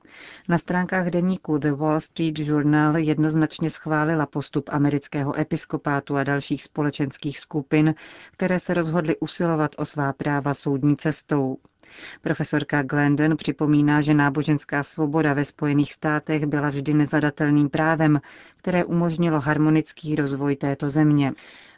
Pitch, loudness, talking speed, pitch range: 150 Hz, -23 LUFS, 120 wpm, 145-155 Hz